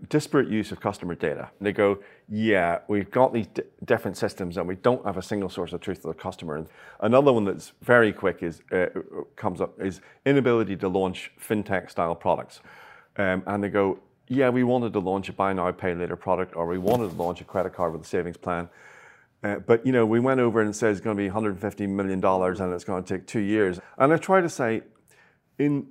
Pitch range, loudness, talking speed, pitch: 90-115 Hz, -25 LUFS, 235 wpm, 100 Hz